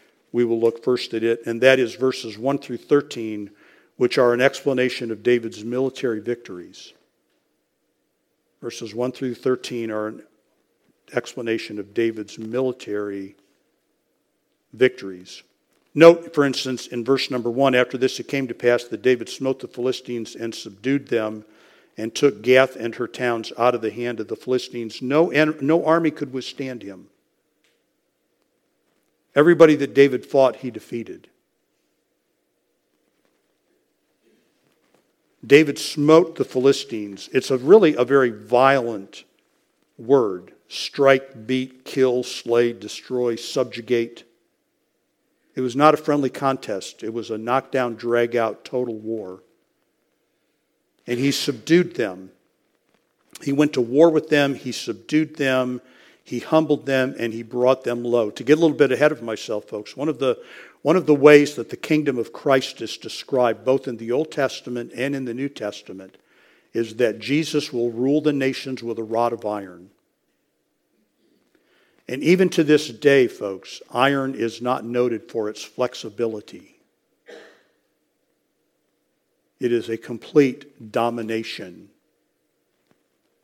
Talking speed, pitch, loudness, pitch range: 140 wpm, 125 Hz, -21 LUFS, 115-140 Hz